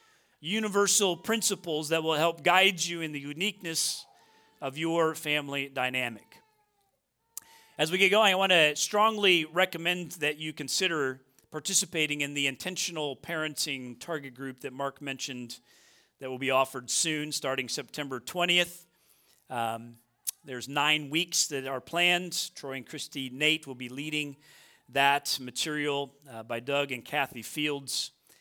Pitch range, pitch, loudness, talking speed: 135-170 Hz, 150 Hz, -28 LUFS, 140 wpm